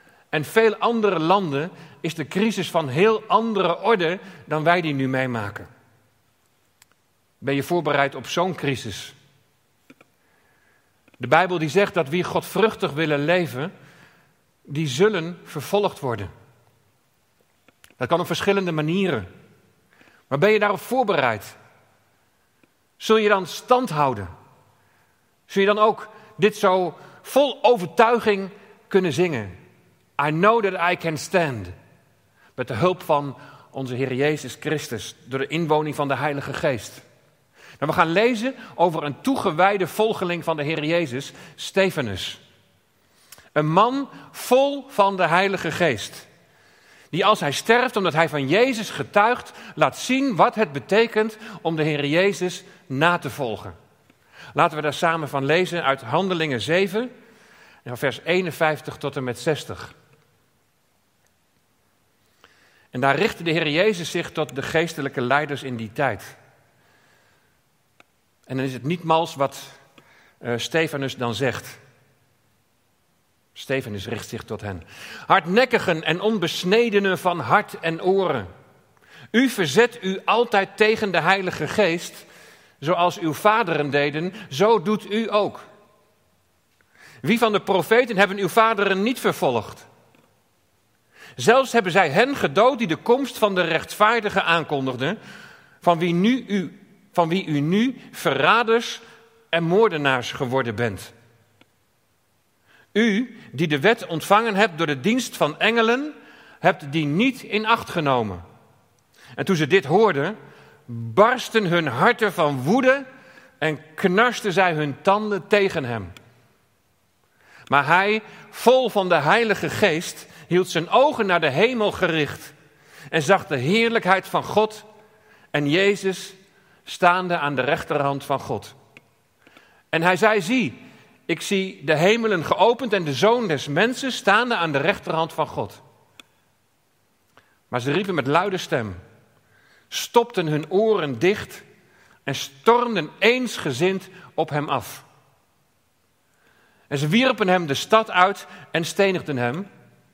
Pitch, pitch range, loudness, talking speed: 170 Hz, 140-205 Hz, -21 LUFS, 135 wpm